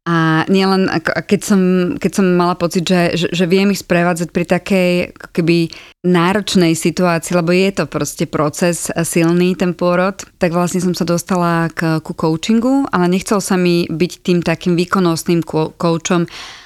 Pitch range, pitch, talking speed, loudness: 170-185 Hz, 175 Hz, 155 wpm, -15 LUFS